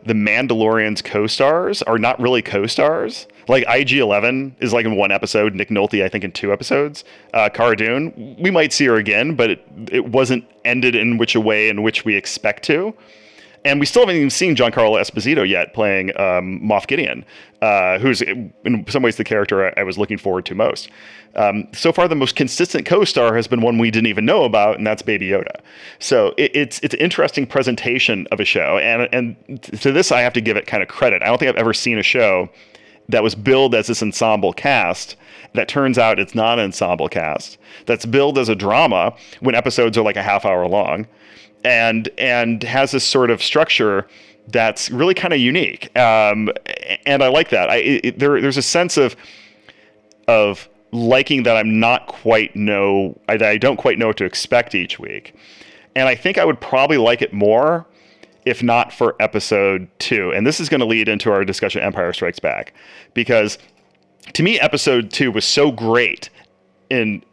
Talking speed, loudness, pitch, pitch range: 200 wpm, -16 LUFS, 115 Hz, 105-130 Hz